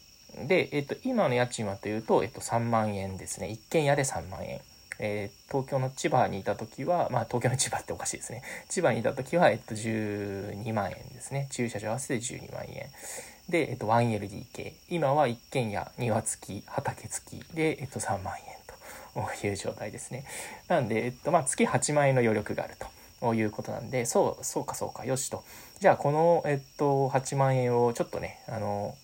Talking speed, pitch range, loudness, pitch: 340 characters per minute, 110-135 Hz, -30 LUFS, 120 Hz